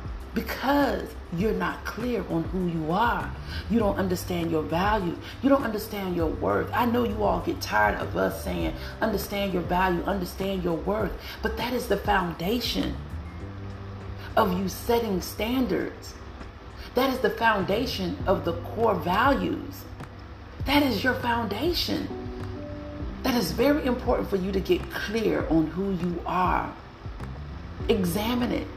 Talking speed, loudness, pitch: 145 wpm, -27 LUFS, 185 Hz